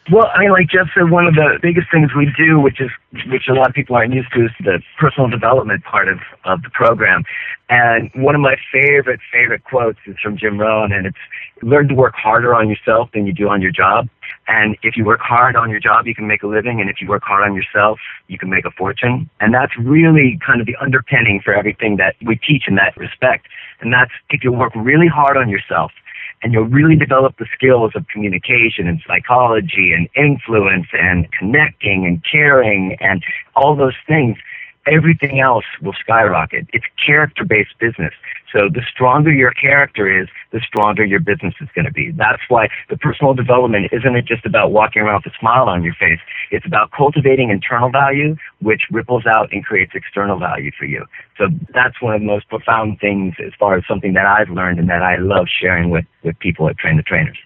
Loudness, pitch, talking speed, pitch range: -13 LUFS, 115 Hz, 215 wpm, 105-135 Hz